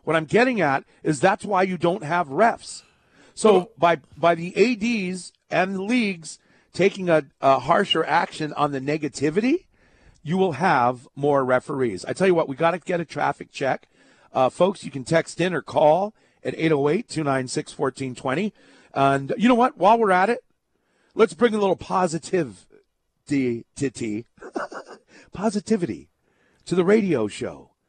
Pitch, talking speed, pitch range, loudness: 170 Hz, 155 wpm, 140-195 Hz, -22 LUFS